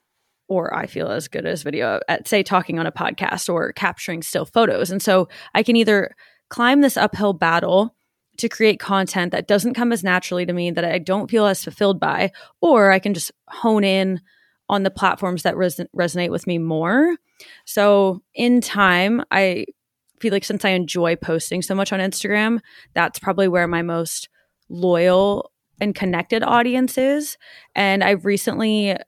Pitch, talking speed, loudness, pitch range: 195 Hz, 175 wpm, -19 LUFS, 180-220 Hz